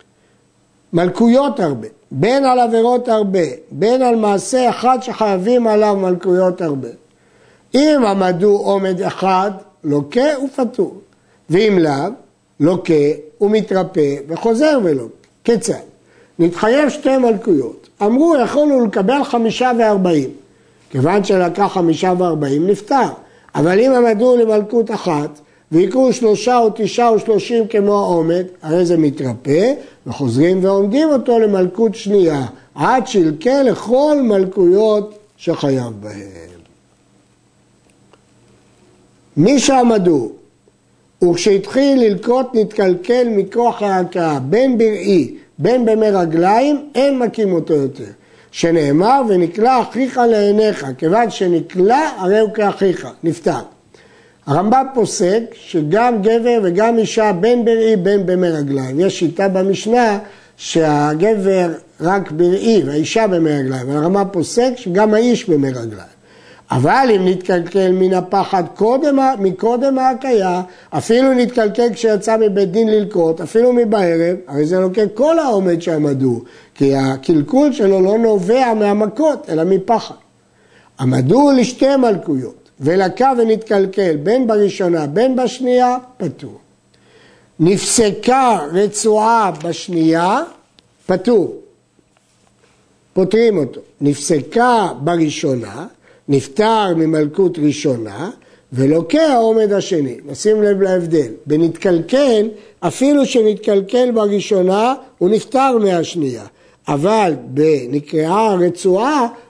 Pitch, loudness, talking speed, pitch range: 200 Hz, -15 LUFS, 100 wpm, 170-235 Hz